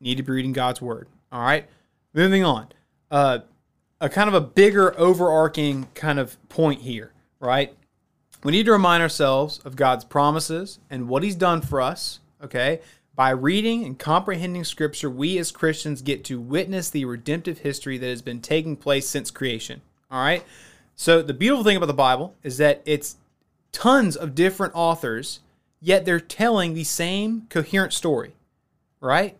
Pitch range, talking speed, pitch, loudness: 135-180 Hz, 165 wpm, 155 Hz, -22 LUFS